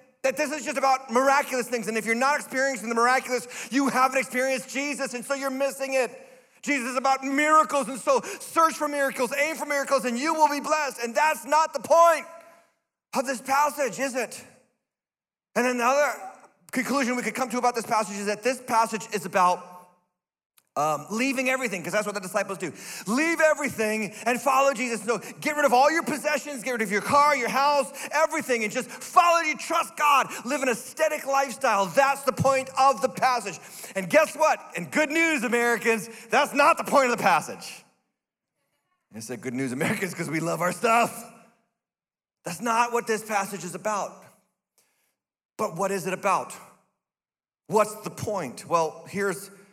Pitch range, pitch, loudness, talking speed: 215-280 Hz, 255 Hz, -24 LUFS, 185 wpm